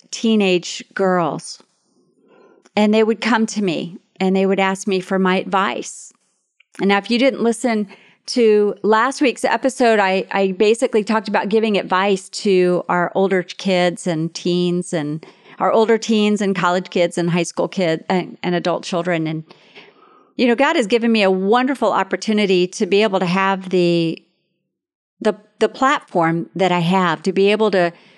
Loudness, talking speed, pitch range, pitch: -18 LUFS, 170 wpm, 180-220 Hz, 195 Hz